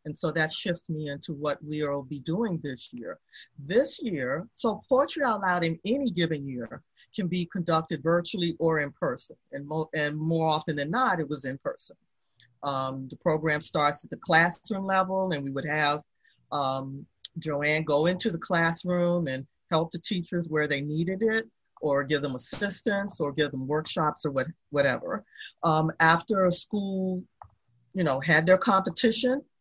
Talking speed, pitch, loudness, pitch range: 175 wpm, 160 Hz, -27 LUFS, 145-185 Hz